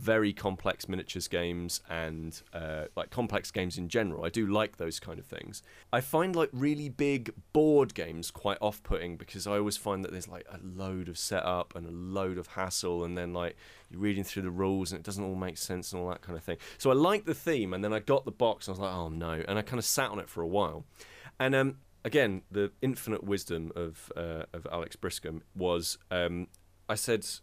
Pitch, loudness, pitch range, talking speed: 95 Hz, -33 LUFS, 85-105 Hz, 230 wpm